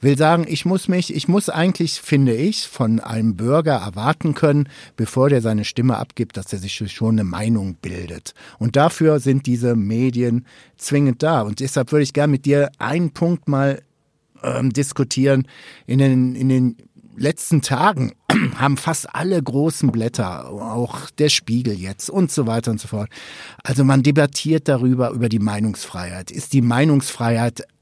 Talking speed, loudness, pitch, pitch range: 165 wpm, -19 LUFS, 135 Hz, 115-150 Hz